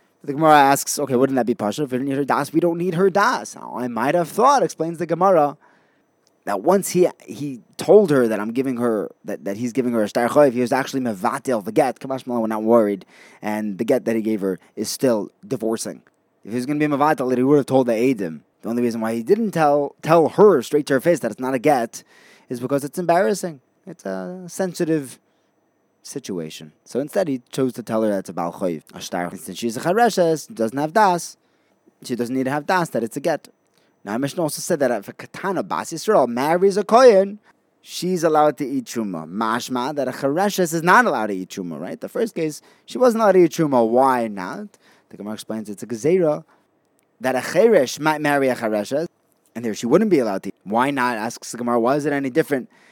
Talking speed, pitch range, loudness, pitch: 230 wpm, 115-165 Hz, -20 LUFS, 135 Hz